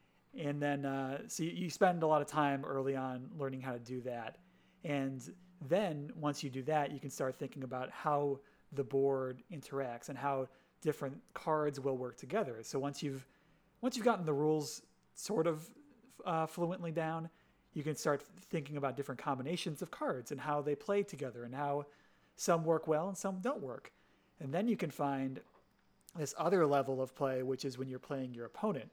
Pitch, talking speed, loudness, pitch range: 145 Hz, 190 wpm, -38 LUFS, 135-165 Hz